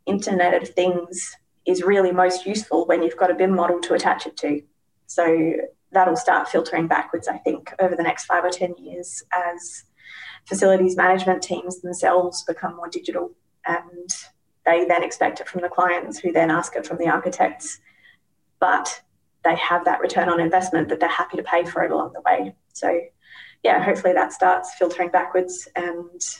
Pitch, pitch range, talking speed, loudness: 180 Hz, 175-185 Hz, 180 wpm, -21 LUFS